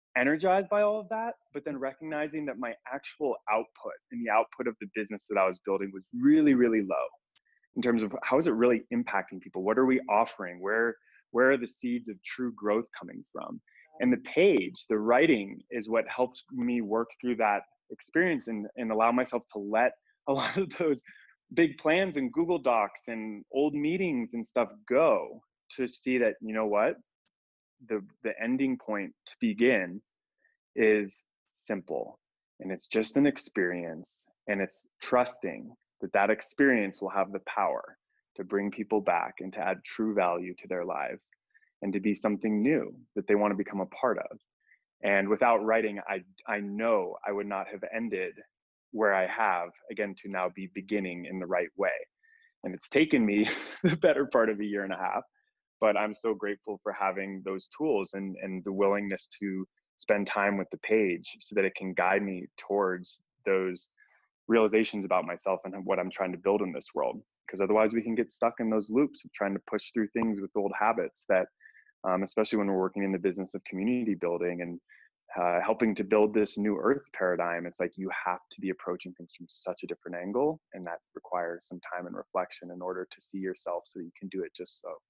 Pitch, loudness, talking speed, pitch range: 105 Hz, -30 LUFS, 200 wpm, 95-125 Hz